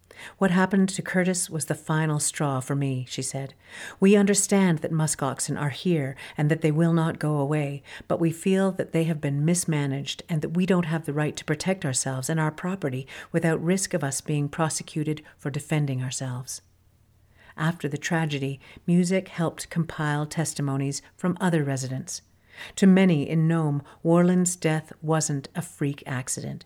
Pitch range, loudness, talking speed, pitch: 140-175 Hz, -25 LUFS, 170 wpm, 155 Hz